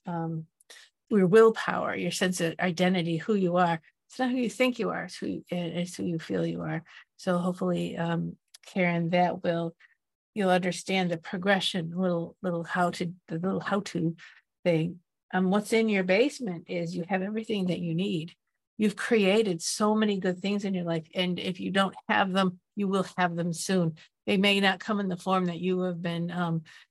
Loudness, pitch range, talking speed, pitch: -28 LUFS, 170-195 Hz, 190 wpm, 180 Hz